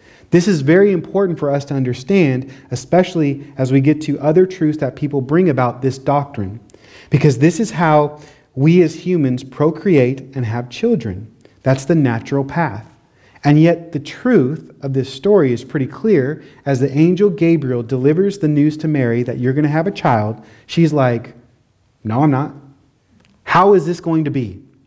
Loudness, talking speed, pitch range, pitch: -16 LUFS, 175 wpm, 130-165 Hz, 145 Hz